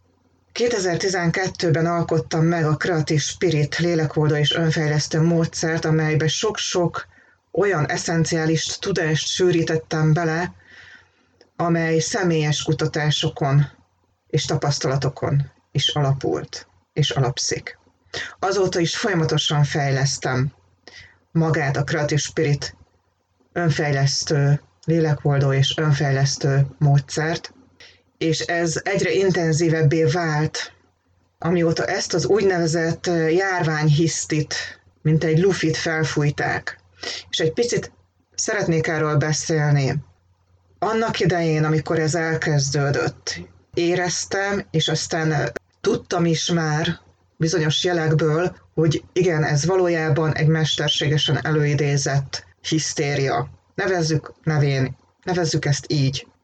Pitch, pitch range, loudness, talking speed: 155 Hz, 140-165 Hz, -21 LUFS, 90 wpm